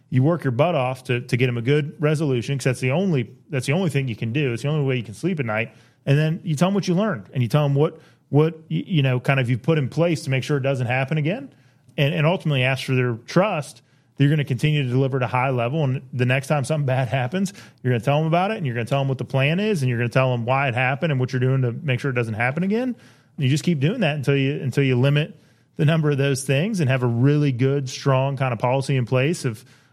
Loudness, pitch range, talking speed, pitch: -22 LUFS, 130-155 Hz, 305 wpm, 140 Hz